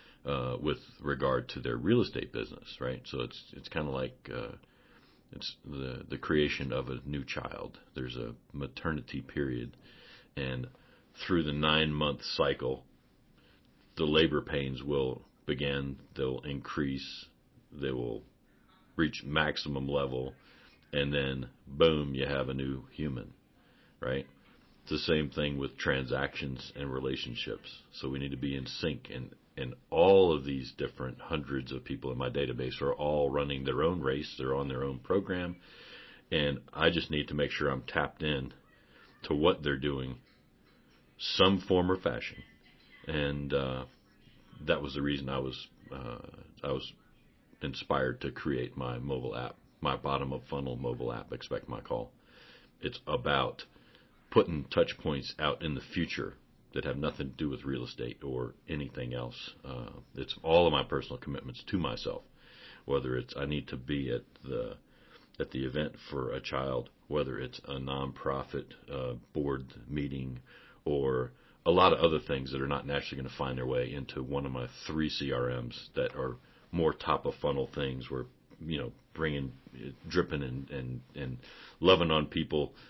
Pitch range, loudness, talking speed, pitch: 65-75 Hz, -34 LUFS, 165 wpm, 70 Hz